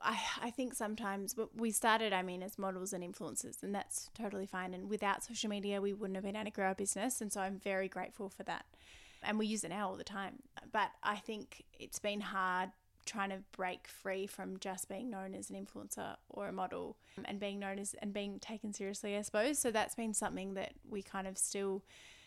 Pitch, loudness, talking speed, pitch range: 200 Hz, -40 LUFS, 225 wpm, 190-215 Hz